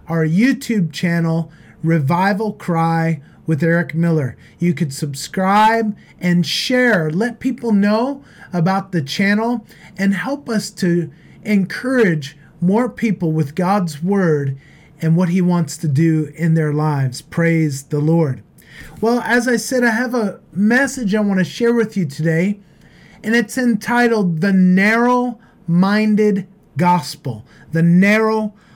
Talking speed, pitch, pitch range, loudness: 135 wpm, 185 Hz, 165-220 Hz, -17 LUFS